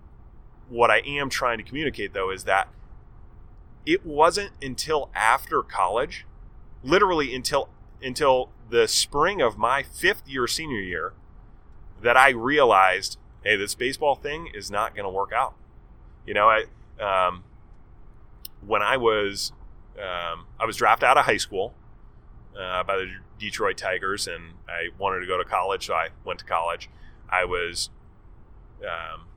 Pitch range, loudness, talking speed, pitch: 100-155 Hz, -24 LUFS, 150 wpm, 130 Hz